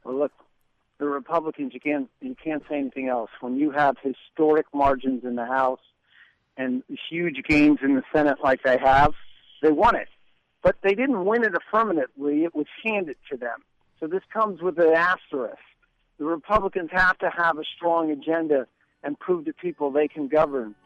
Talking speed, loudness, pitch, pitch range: 180 wpm, -24 LUFS, 150 Hz, 135-175 Hz